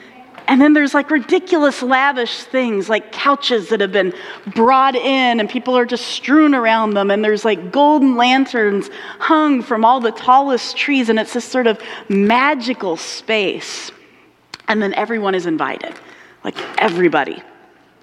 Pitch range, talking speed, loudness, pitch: 220-270 Hz, 155 wpm, -15 LUFS, 245 Hz